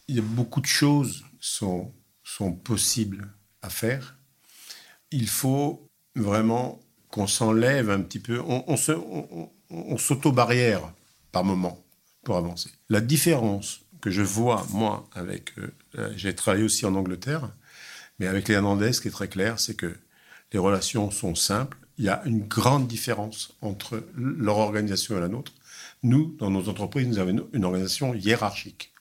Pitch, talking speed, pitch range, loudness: 110 Hz, 160 wpm, 100-125 Hz, -26 LUFS